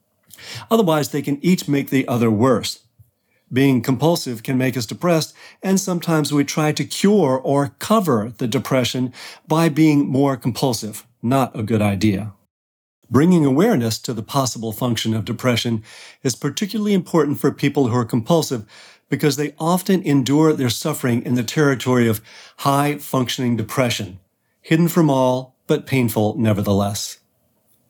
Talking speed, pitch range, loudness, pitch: 145 wpm, 115-150 Hz, -19 LUFS, 130 Hz